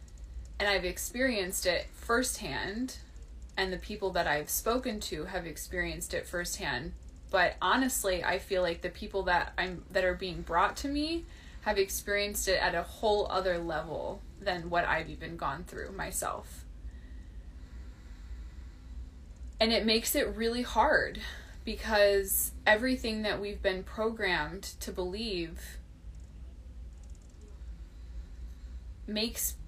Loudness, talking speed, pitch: -31 LUFS, 125 wpm, 180 Hz